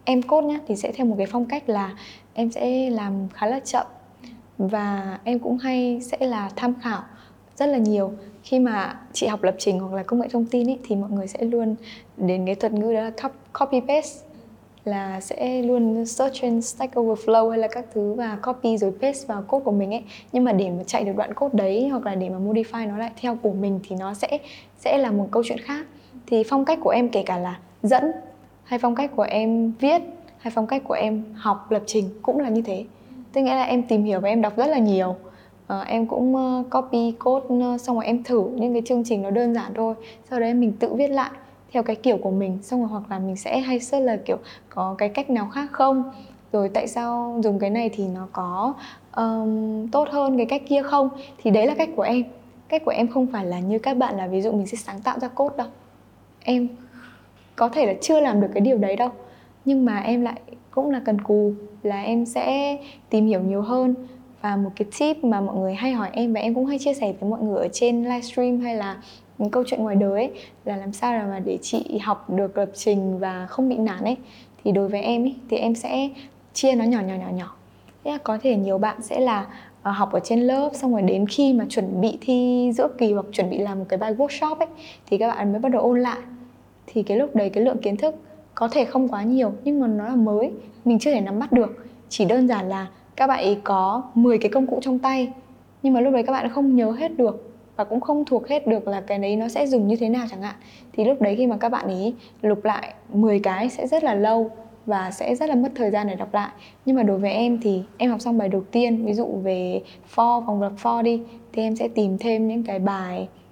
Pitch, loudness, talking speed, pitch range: 230 Hz, -23 LUFS, 250 wpm, 205-255 Hz